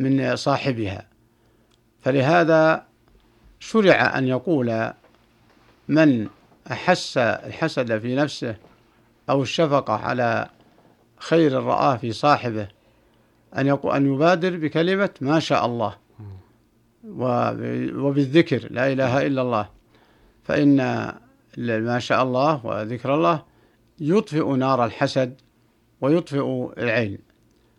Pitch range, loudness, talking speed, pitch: 115-145 Hz, -21 LUFS, 90 wpm, 130 Hz